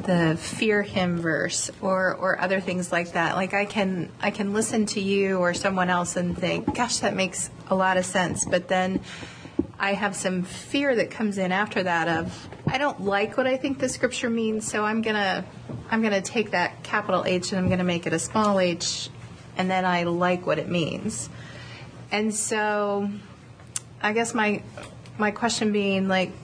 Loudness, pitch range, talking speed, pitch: -25 LUFS, 180-215 Hz, 195 wpm, 195 Hz